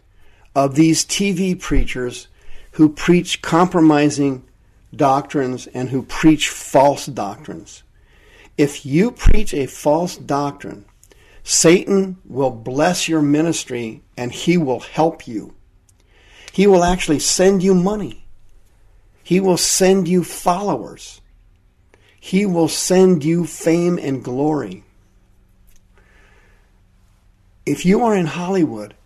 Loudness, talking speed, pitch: -17 LUFS, 105 wpm, 140 Hz